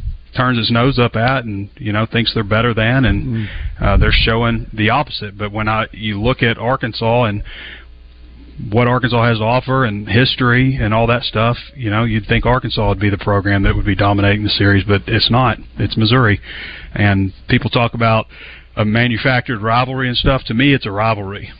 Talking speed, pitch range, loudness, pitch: 195 wpm, 105-120 Hz, -15 LUFS, 115 Hz